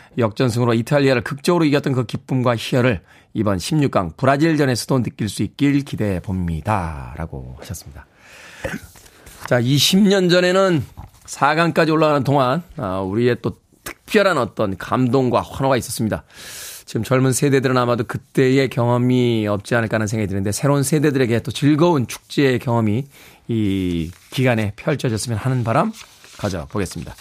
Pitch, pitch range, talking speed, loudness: 125 Hz, 110-140 Hz, 340 characters per minute, -19 LUFS